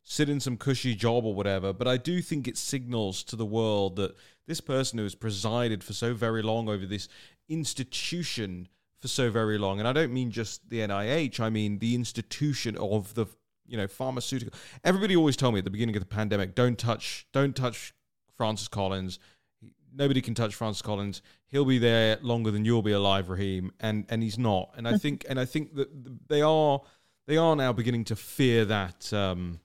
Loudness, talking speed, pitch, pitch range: -29 LUFS, 200 wpm, 115 Hz, 105-130 Hz